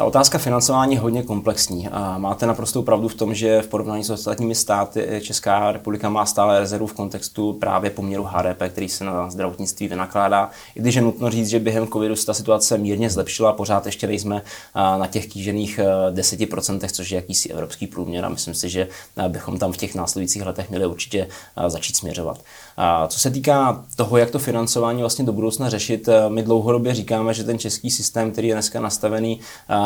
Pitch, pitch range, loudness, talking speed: 105 Hz, 100-115 Hz, -21 LUFS, 185 wpm